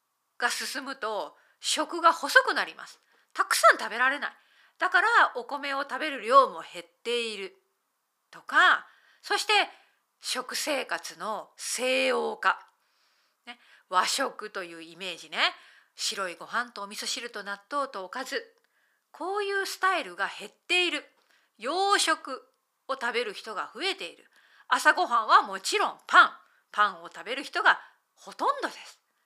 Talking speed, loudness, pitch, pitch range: 275 characters per minute, -26 LUFS, 265 Hz, 210-340 Hz